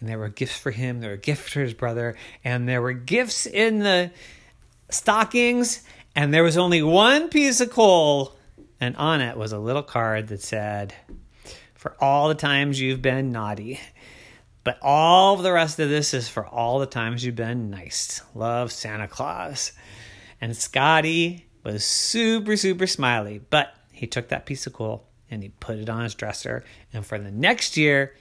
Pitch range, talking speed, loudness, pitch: 110-160 Hz, 180 wpm, -22 LUFS, 130 Hz